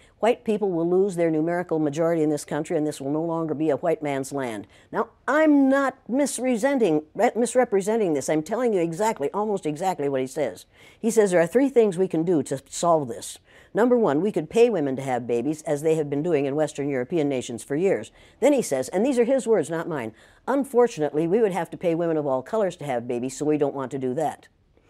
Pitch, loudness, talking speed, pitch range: 165 Hz, -24 LUFS, 230 wpm, 140-215 Hz